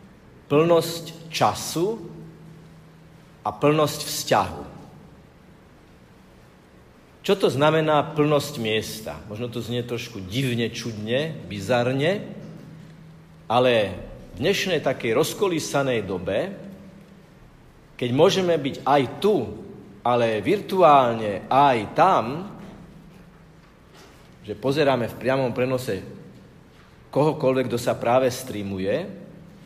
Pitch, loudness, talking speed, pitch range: 150 Hz, -23 LUFS, 85 wpm, 125-165 Hz